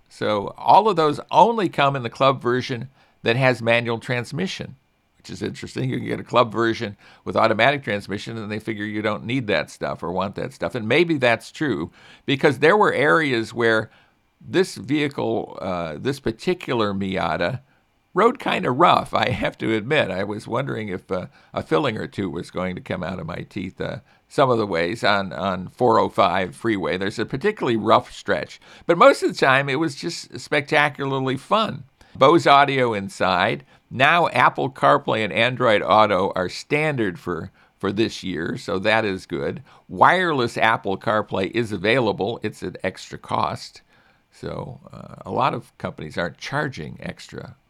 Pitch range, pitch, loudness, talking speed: 105-140 Hz, 120 Hz, -21 LUFS, 175 wpm